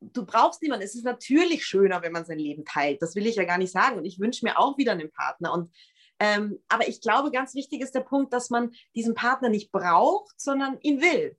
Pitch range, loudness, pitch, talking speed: 190-275 Hz, -25 LUFS, 235 Hz, 240 wpm